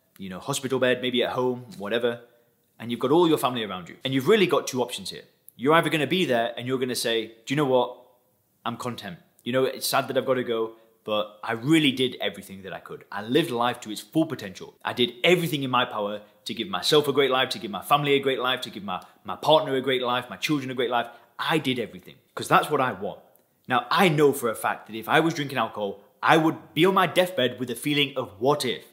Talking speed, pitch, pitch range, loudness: 260 wpm, 125 Hz, 115-145 Hz, -24 LUFS